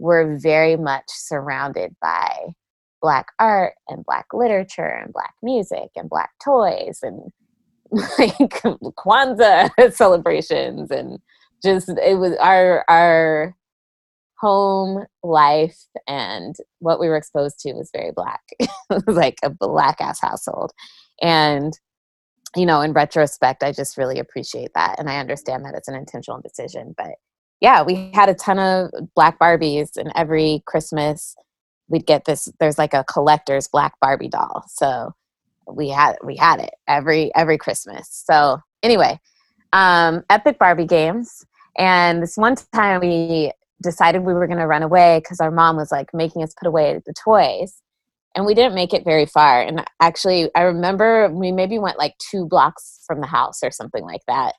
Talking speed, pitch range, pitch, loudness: 160 wpm, 155-195 Hz, 170 Hz, -17 LUFS